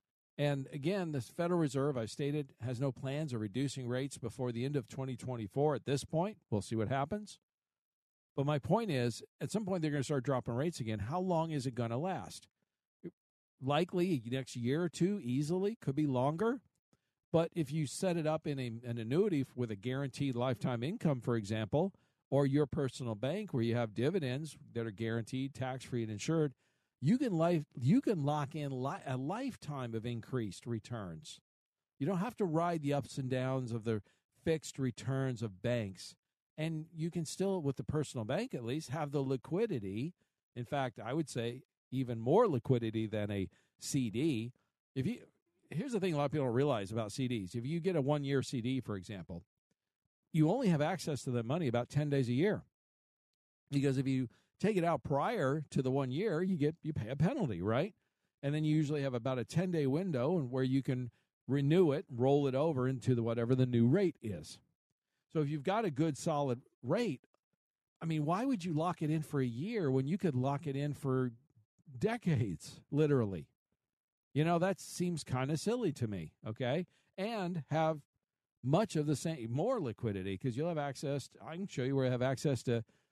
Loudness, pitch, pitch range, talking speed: -36 LUFS, 140 Hz, 125-160 Hz, 200 wpm